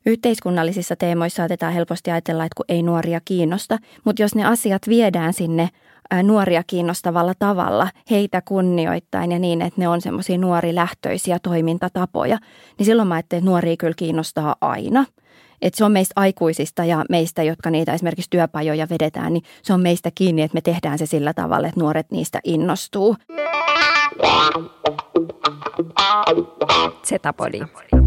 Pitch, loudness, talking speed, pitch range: 175 Hz, -19 LUFS, 145 wpm, 165-190 Hz